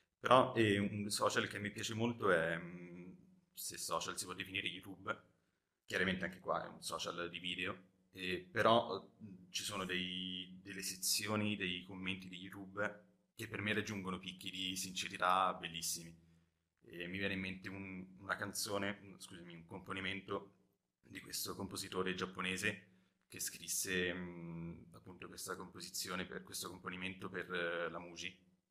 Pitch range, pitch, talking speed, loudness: 90-100 Hz, 95 Hz, 140 wpm, -40 LUFS